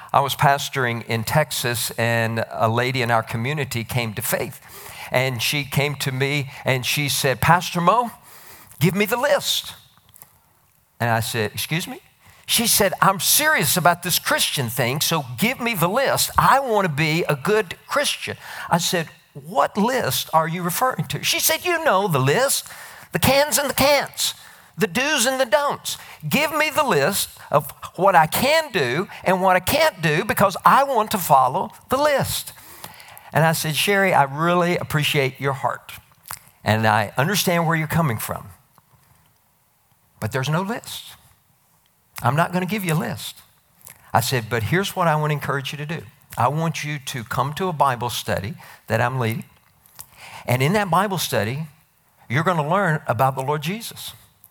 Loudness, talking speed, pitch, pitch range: -20 LUFS, 180 wpm, 150 Hz, 130-190 Hz